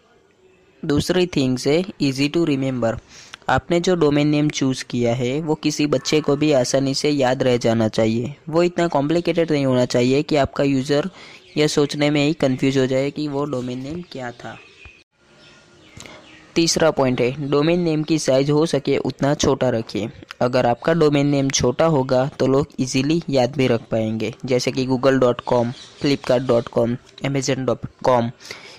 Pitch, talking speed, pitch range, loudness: 135 Hz, 170 wpm, 125-150 Hz, -19 LUFS